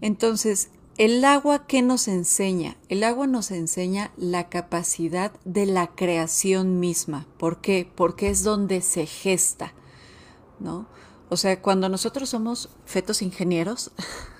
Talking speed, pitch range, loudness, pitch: 130 wpm, 175-215 Hz, -23 LUFS, 190 Hz